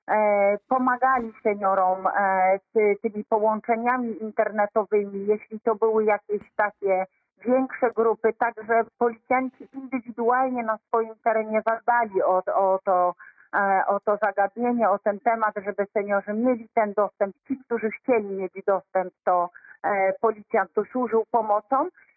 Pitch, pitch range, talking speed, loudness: 220 Hz, 200-235 Hz, 125 wpm, -24 LUFS